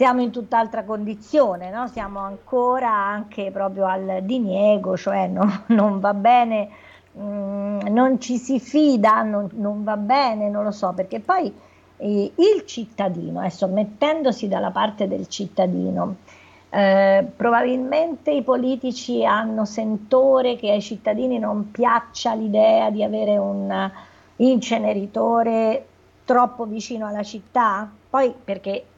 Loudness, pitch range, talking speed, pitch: -21 LUFS, 200-245 Hz, 130 wpm, 215 Hz